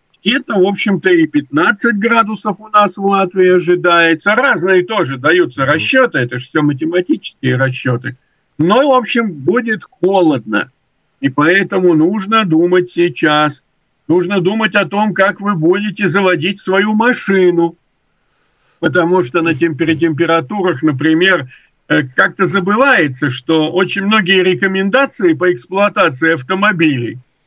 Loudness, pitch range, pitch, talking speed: -13 LUFS, 160-205 Hz, 180 Hz, 120 wpm